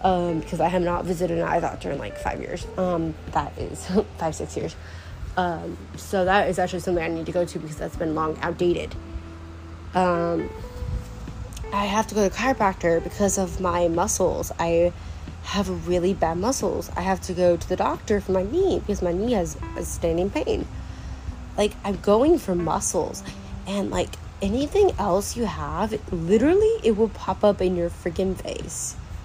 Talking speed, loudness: 185 wpm, -24 LUFS